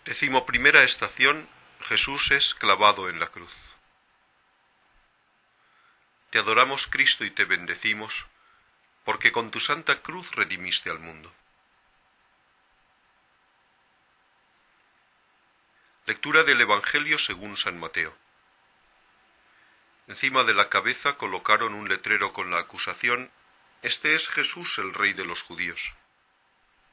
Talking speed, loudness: 105 wpm, -23 LUFS